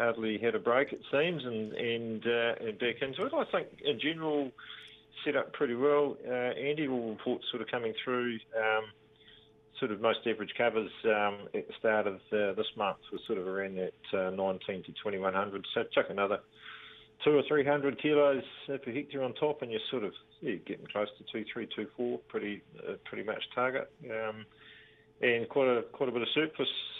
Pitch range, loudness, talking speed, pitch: 110-135 Hz, -33 LUFS, 205 wpm, 115 Hz